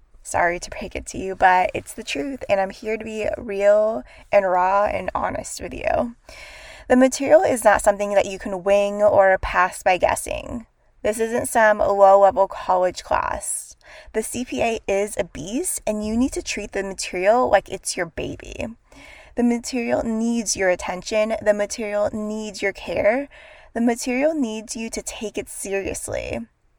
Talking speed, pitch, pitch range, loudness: 170 wpm, 215 Hz, 195-245 Hz, -21 LUFS